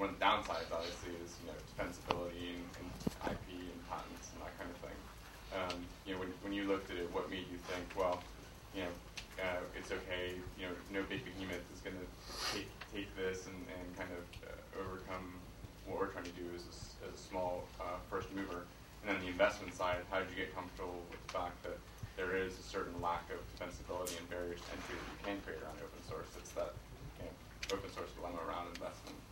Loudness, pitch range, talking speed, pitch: -43 LUFS, 90-95 Hz, 220 wpm, 90 Hz